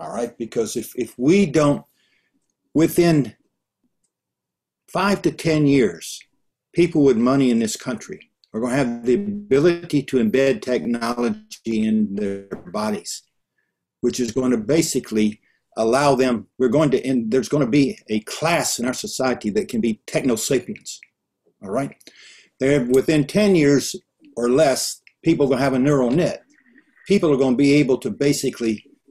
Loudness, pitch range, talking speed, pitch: -20 LUFS, 120-165 Hz, 165 wpm, 135 Hz